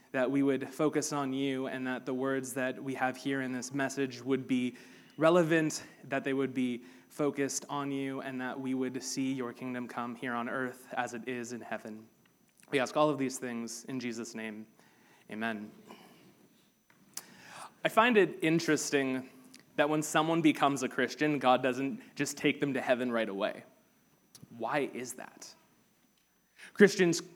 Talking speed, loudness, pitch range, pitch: 165 wpm, -32 LUFS, 125-140 Hz, 130 Hz